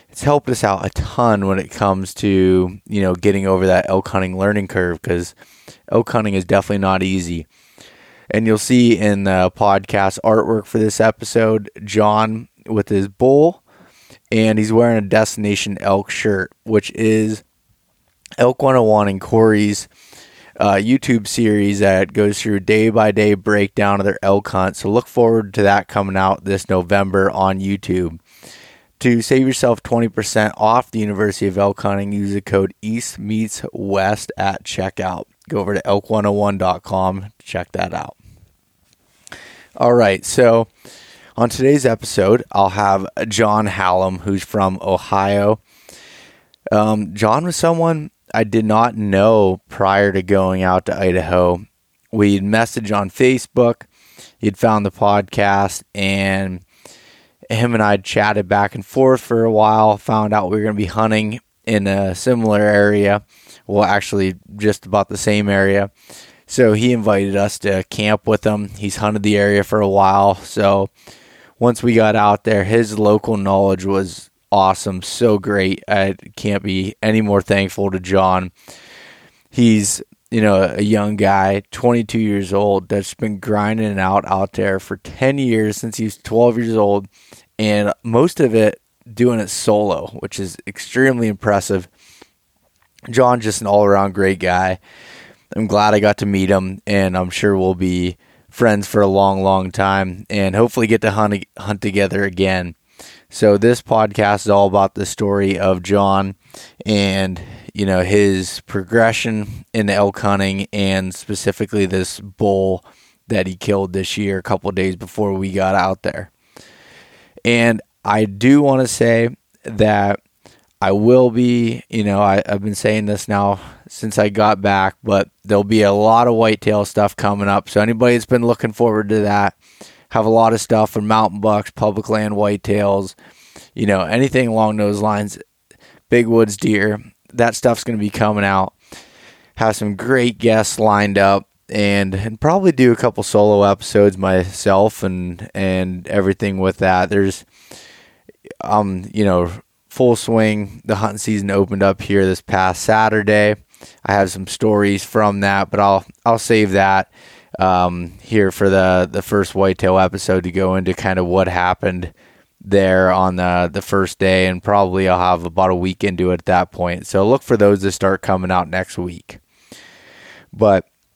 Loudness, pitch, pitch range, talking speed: -16 LUFS, 100 Hz, 95-110 Hz, 165 wpm